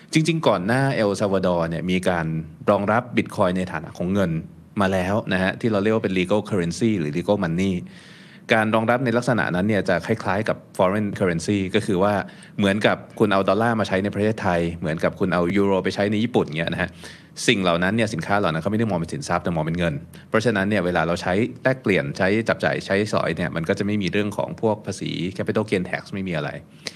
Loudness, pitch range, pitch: -22 LUFS, 90-110 Hz, 100 Hz